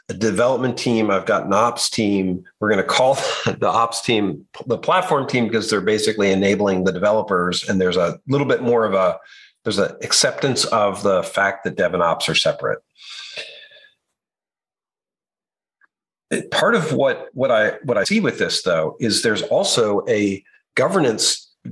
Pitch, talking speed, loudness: 110 Hz, 165 wpm, -19 LUFS